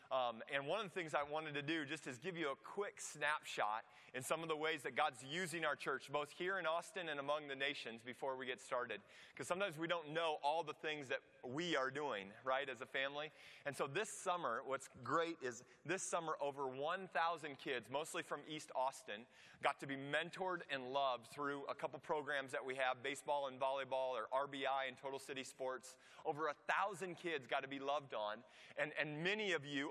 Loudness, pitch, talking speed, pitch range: -43 LUFS, 145 Hz, 215 wpm, 135-165 Hz